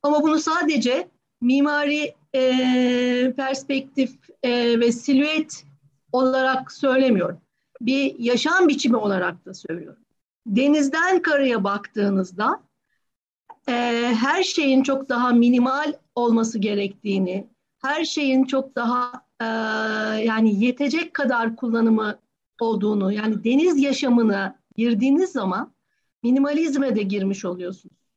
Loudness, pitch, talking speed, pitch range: -21 LUFS, 245 Hz, 100 wpm, 220-275 Hz